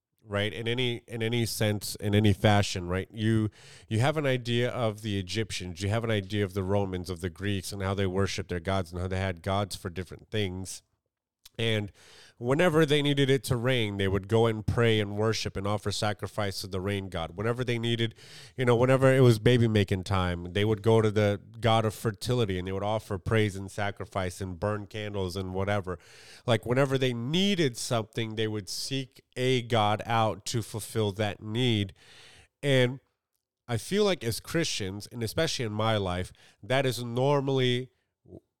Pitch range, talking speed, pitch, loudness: 100-120 Hz, 190 wpm, 110 Hz, -28 LUFS